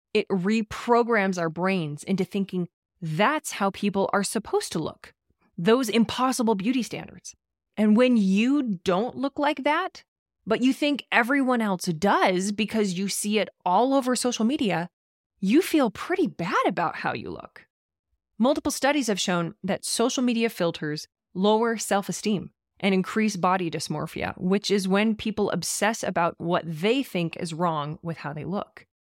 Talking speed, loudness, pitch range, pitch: 155 wpm, -25 LUFS, 180-235 Hz, 205 Hz